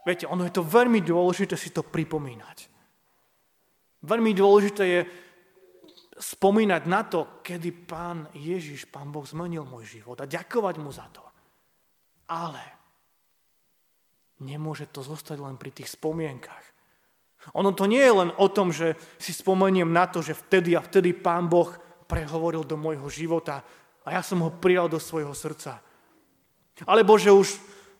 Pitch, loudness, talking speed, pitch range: 170 Hz, -24 LUFS, 150 wpm, 155-190 Hz